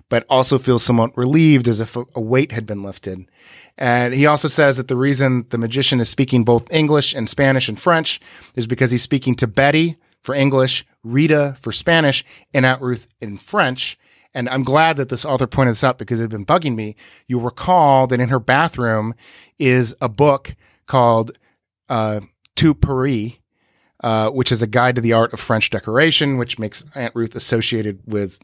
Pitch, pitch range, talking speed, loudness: 125 Hz, 115-135 Hz, 190 wpm, -17 LUFS